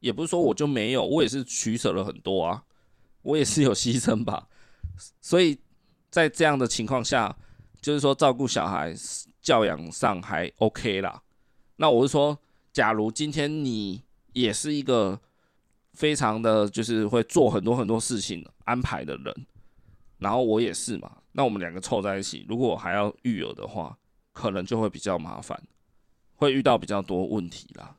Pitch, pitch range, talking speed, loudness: 120 Hz, 110-145 Hz, 255 characters per minute, -26 LUFS